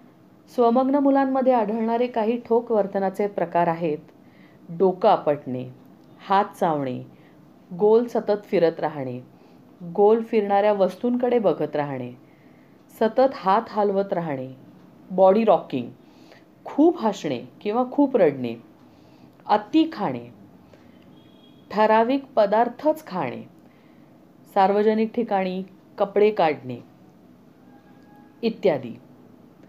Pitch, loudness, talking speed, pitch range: 200 Hz, -22 LUFS, 85 wpm, 155-230 Hz